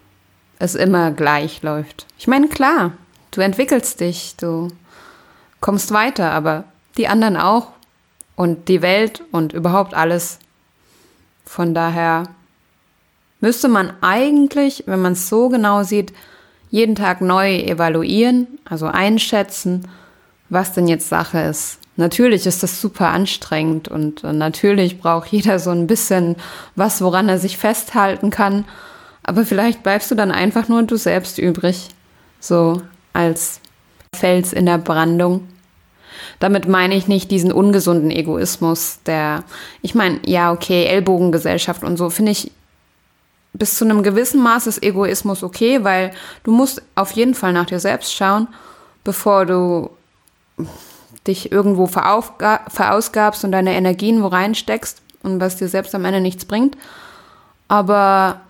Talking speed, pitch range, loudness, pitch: 135 wpm, 175-210 Hz, -16 LUFS, 190 Hz